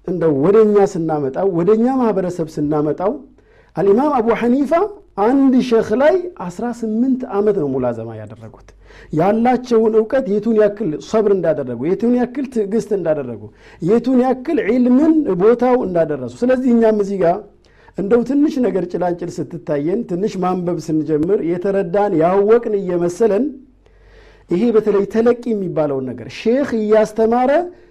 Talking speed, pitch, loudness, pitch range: 115 wpm, 210 Hz, -16 LUFS, 170-240 Hz